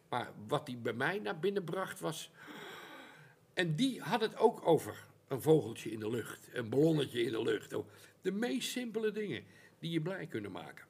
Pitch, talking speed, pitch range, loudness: 180 Hz, 185 wpm, 140-220 Hz, -36 LUFS